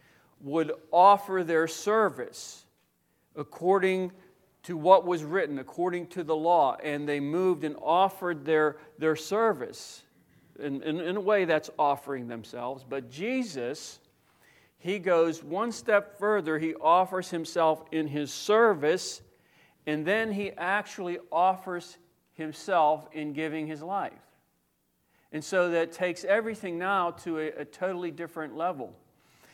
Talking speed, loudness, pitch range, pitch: 130 wpm, -28 LUFS, 155-190 Hz, 170 Hz